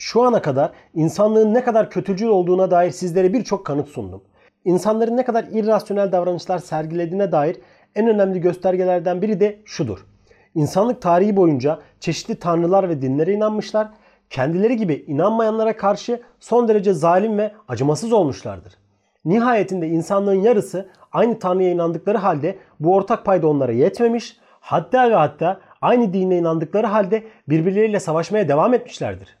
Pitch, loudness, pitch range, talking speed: 190 Hz, -19 LUFS, 165-215 Hz, 135 wpm